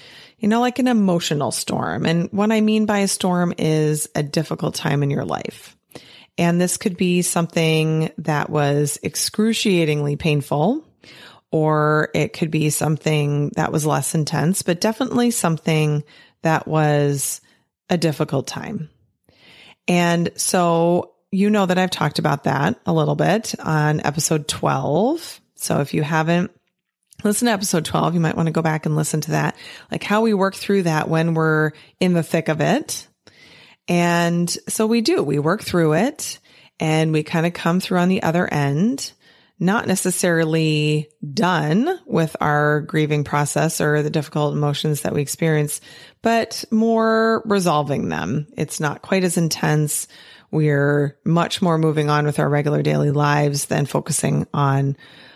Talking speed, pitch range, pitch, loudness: 160 wpm, 150-185 Hz, 160 Hz, -20 LUFS